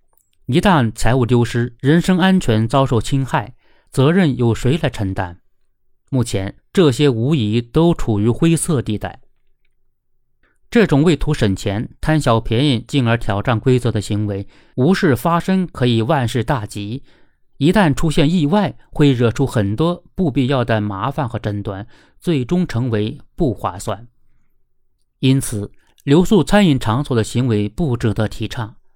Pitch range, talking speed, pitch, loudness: 110-155 Hz, 220 characters per minute, 125 Hz, -17 LUFS